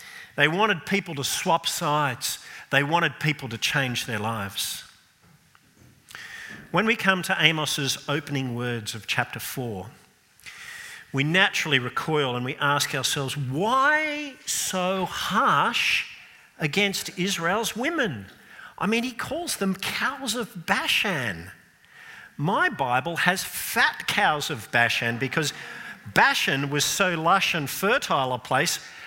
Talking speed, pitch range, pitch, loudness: 125 wpm, 135-195 Hz, 160 Hz, -24 LUFS